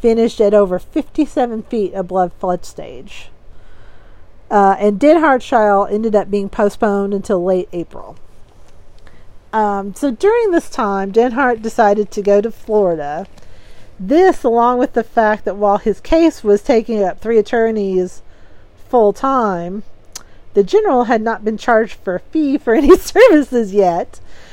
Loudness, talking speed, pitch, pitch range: -14 LUFS, 145 wpm, 210 Hz, 185-235 Hz